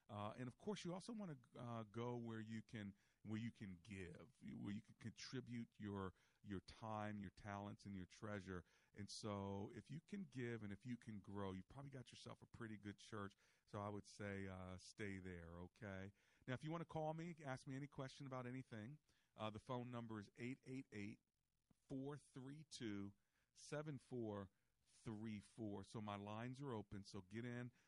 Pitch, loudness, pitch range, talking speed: 110 Hz, -54 LUFS, 100-130 Hz, 180 wpm